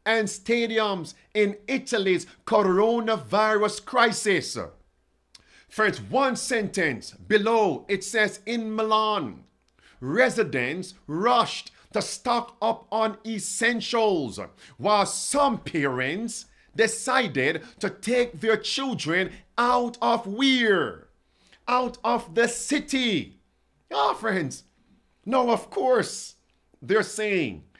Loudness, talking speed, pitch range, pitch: -25 LUFS, 95 wpm, 205-235 Hz, 220 Hz